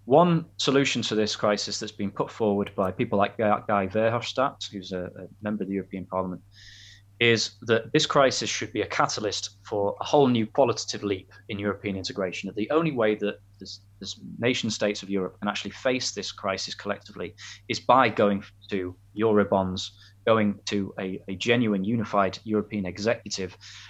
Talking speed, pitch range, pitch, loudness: 170 wpm, 100-110 Hz, 105 Hz, -26 LUFS